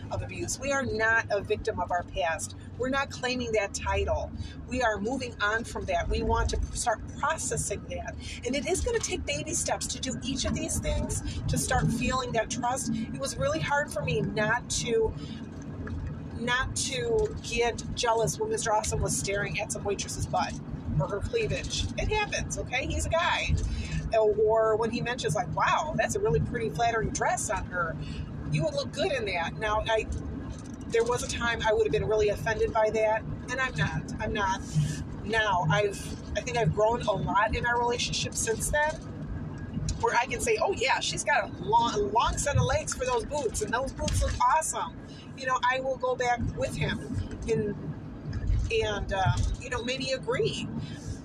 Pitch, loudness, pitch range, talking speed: 240 Hz, -29 LUFS, 220-285 Hz, 195 wpm